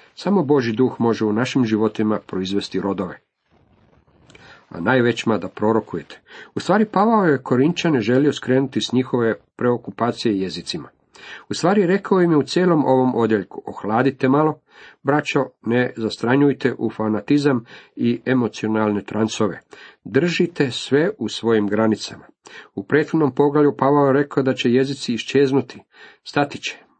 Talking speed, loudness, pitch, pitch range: 135 wpm, -19 LUFS, 130 Hz, 110-145 Hz